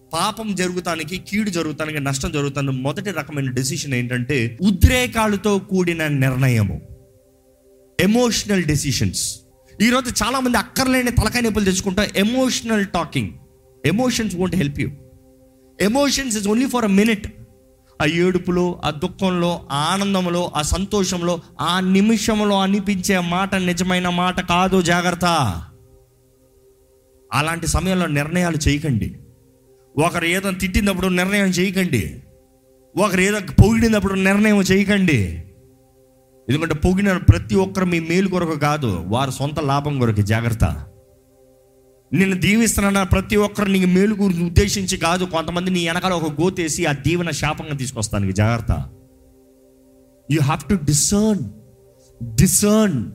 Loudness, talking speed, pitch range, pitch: -19 LUFS, 110 wpm, 130-195 Hz, 170 Hz